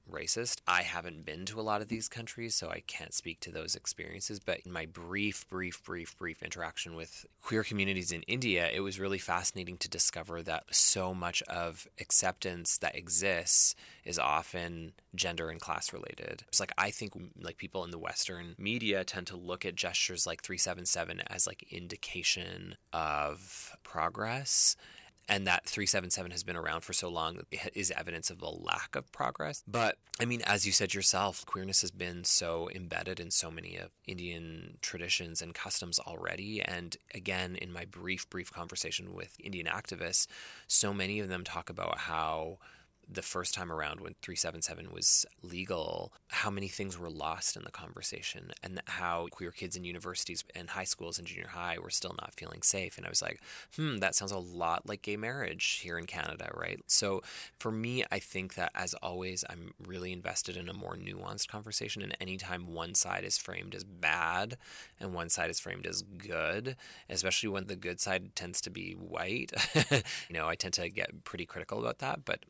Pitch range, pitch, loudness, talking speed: 85-100 Hz, 90 Hz, -32 LUFS, 185 wpm